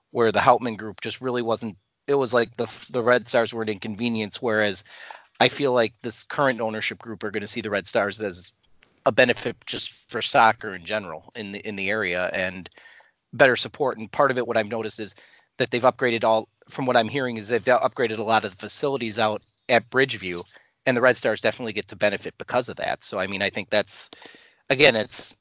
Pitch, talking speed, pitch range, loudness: 110 Hz, 220 wpm, 105-120 Hz, -23 LUFS